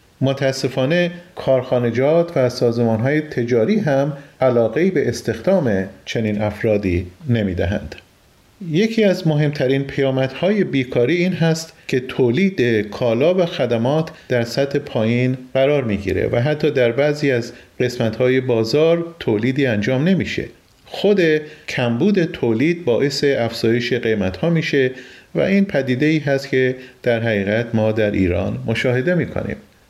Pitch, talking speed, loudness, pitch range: 130 Hz, 135 wpm, -18 LUFS, 115-155 Hz